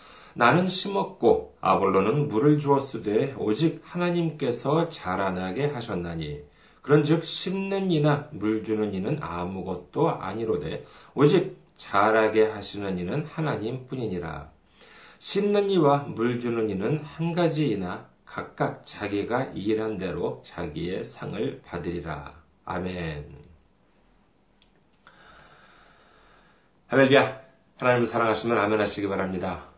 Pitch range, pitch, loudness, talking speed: 95-150 Hz, 115 Hz, -26 LUFS, 250 characters per minute